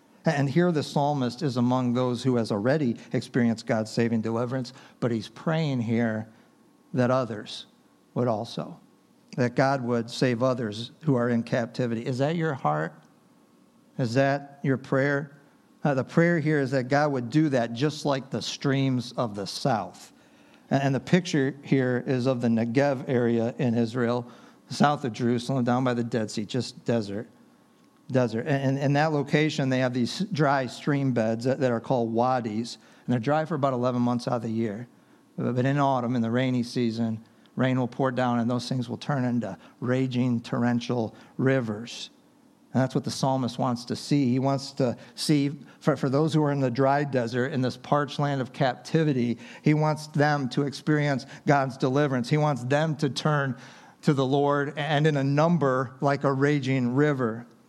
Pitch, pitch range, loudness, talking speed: 130 Hz, 120-145 Hz, -26 LUFS, 180 wpm